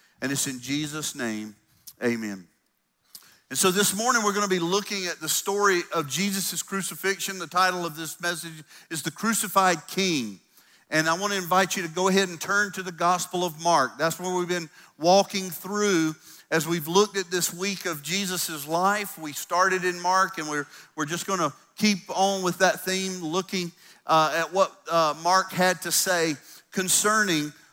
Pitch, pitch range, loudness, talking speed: 180 Hz, 160-195 Hz, -25 LUFS, 185 wpm